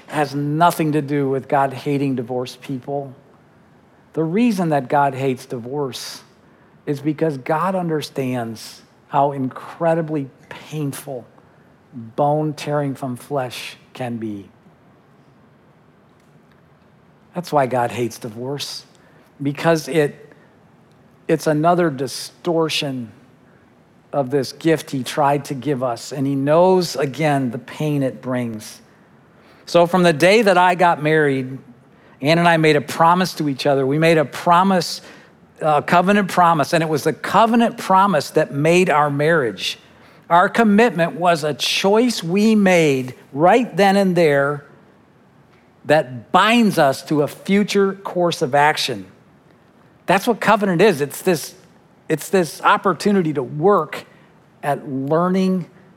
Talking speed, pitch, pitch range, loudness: 130 wpm, 150 Hz, 135-175 Hz, -18 LUFS